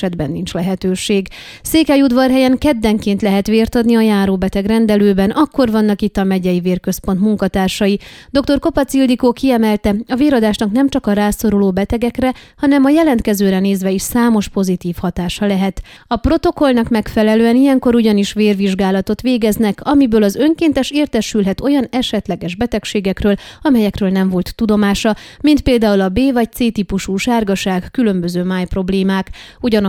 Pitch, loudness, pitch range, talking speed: 215 Hz, -14 LUFS, 195-250 Hz, 140 wpm